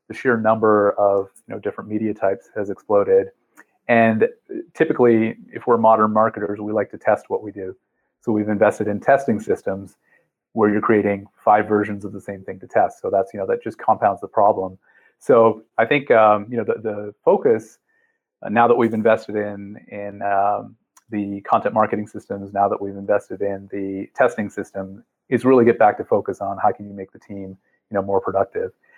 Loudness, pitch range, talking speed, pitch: -19 LUFS, 100-115 Hz, 200 wpm, 105 Hz